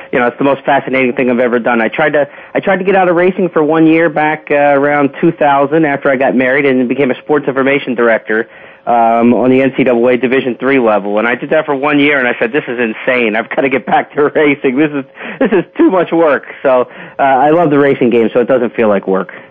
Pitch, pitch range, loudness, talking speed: 140 Hz, 125-150 Hz, -11 LUFS, 260 wpm